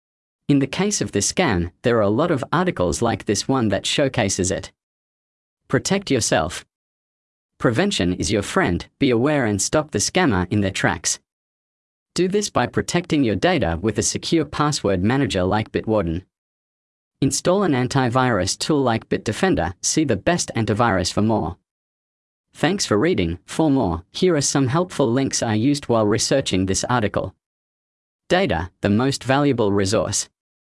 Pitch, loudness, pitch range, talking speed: 115 Hz, -20 LUFS, 95-140 Hz, 155 wpm